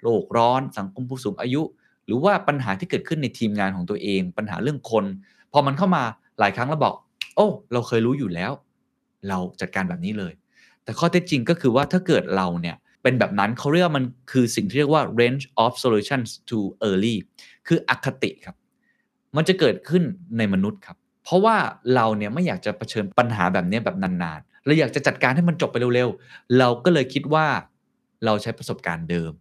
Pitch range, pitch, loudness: 105-155 Hz, 125 Hz, -22 LUFS